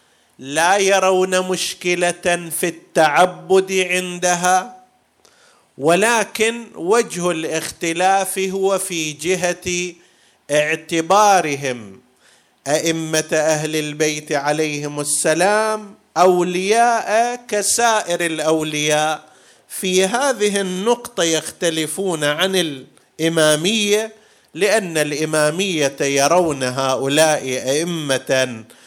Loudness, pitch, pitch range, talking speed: -18 LUFS, 175 Hz, 155-190 Hz, 65 wpm